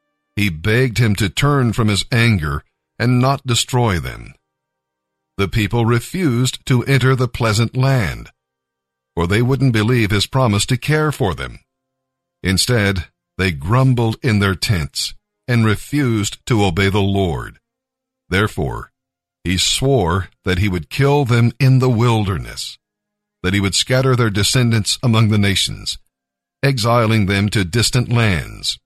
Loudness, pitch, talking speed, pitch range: -17 LUFS, 115 Hz, 140 wpm, 95-130 Hz